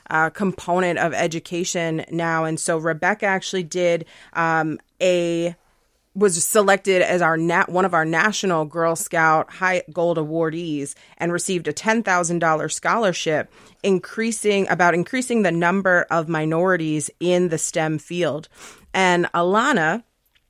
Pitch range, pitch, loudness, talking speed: 160-185 Hz, 175 Hz, -20 LUFS, 135 wpm